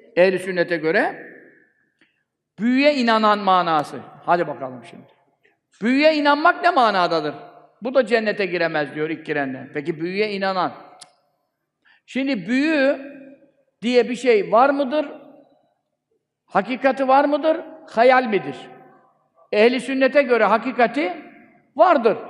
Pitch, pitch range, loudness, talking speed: 255 Hz, 190-285 Hz, -19 LUFS, 110 wpm